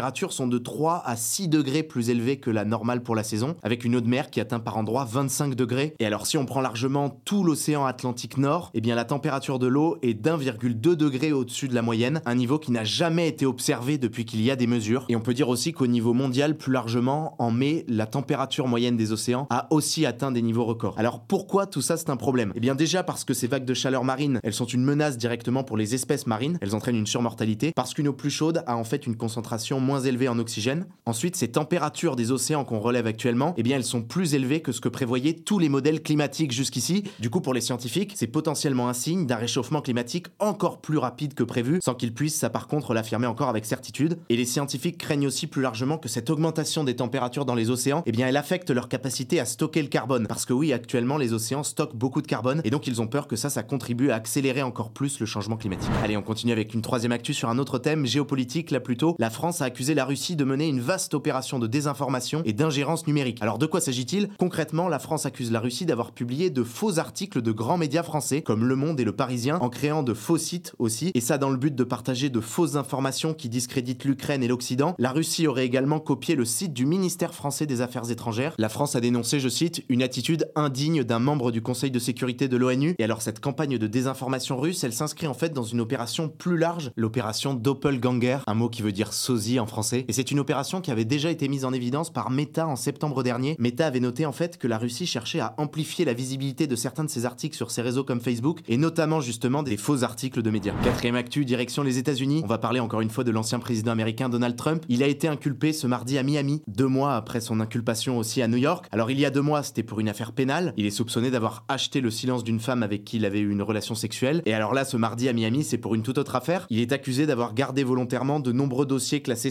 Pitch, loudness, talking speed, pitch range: 130 Hz, -26 LUFS, 250 wpm, 120-150 Hz